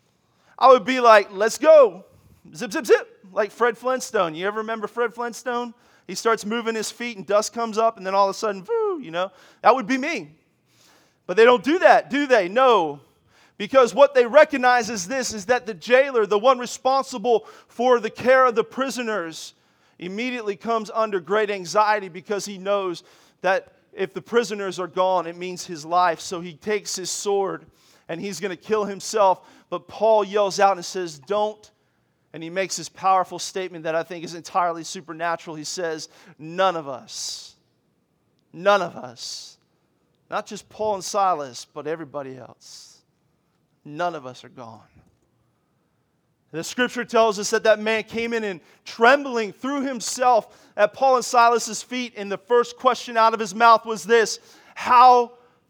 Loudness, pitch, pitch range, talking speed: -21 LUFS, 210 Hz, 180-240 Hz, 175 wpm